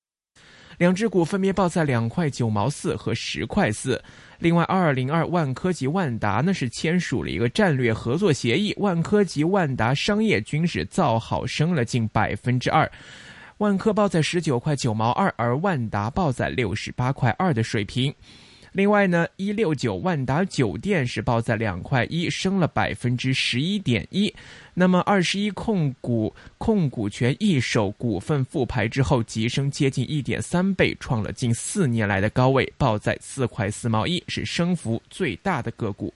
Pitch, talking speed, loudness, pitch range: 135 Hz, 260 characters per minute, -23 LUFS, 115-180 Hz